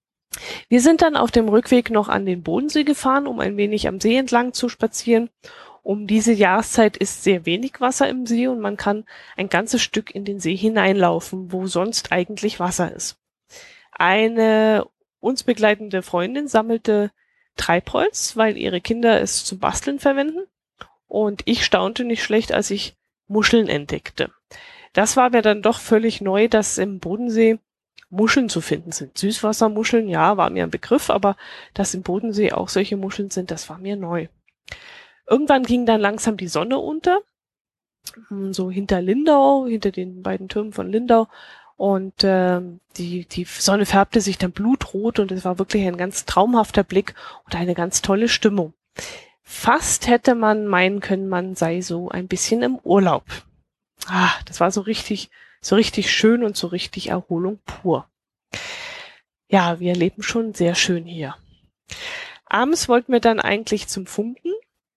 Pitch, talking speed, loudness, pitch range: 215 Hz, 160 wpm, -20 LUFS, 190-240 Hz